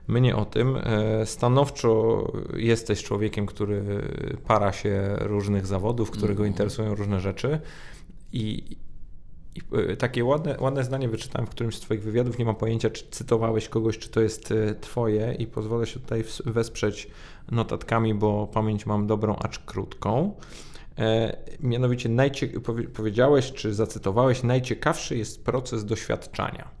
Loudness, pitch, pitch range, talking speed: -26 LUFS, 110 Hz, 105-120 Hz, 130 wpm